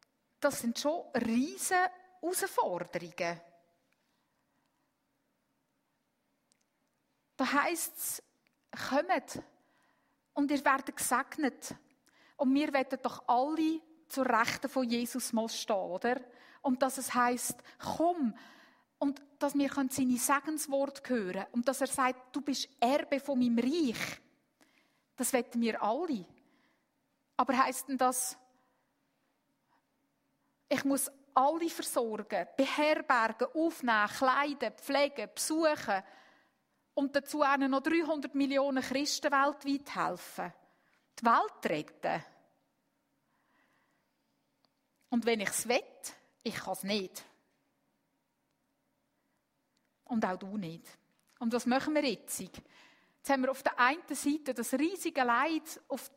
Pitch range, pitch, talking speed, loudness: 245-290 Hz, 270 Hz, 110 wpm, -32 LUFS